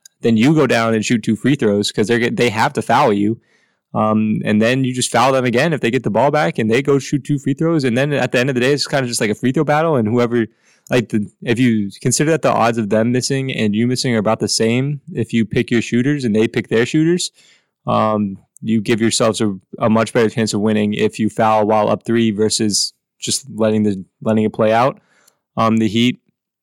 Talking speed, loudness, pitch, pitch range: 250 wpm, -16 LUFS, 115 Hz, 110-130 Hz